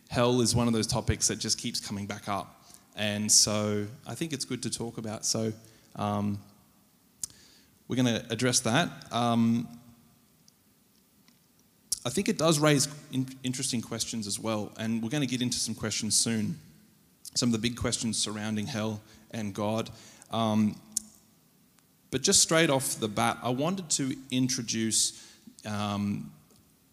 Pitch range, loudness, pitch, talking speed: 110-130 Hz, -28 LUFS, 115 Hz, 155 wpm